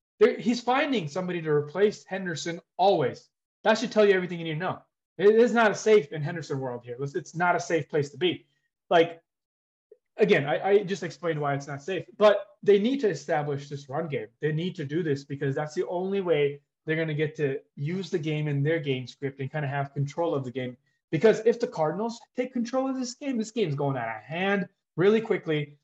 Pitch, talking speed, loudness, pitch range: 170 Hz, 225 wpm, -27 LUFS, 145-205 Hz